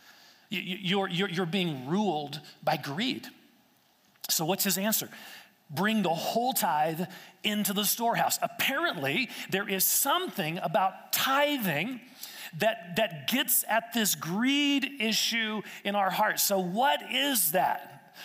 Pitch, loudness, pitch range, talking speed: 205 Hz, -28 LUFS, 185-230 Hz, 125 wpm